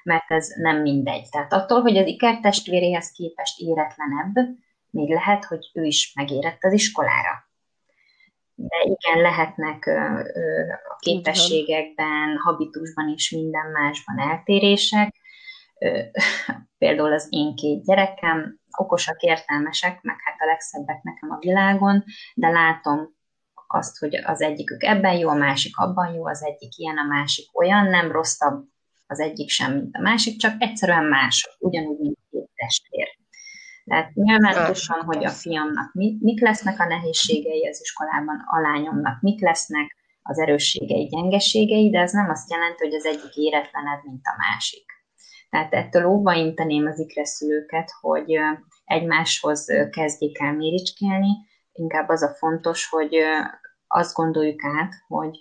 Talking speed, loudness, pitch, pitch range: 135 wpm, -21 LUFS, 165 Hz, 155-200 Hz